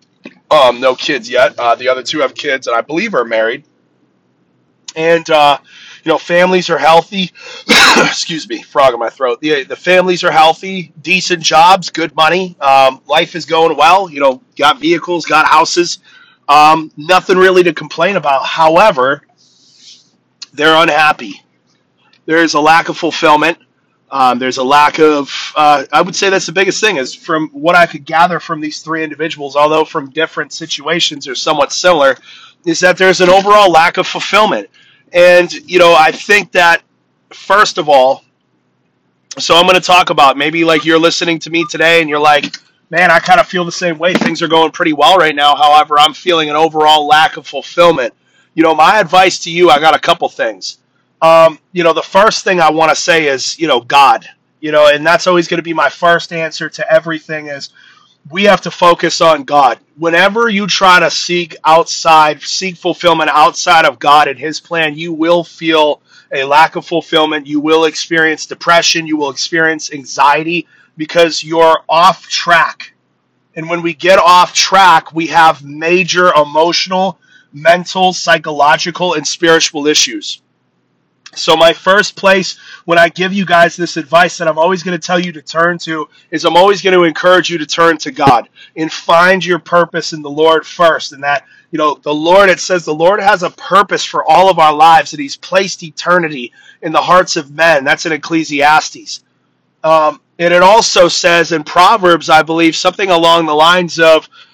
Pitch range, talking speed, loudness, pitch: 155-180 Hz, 185 wpm, -10 LUFS, 165 Hz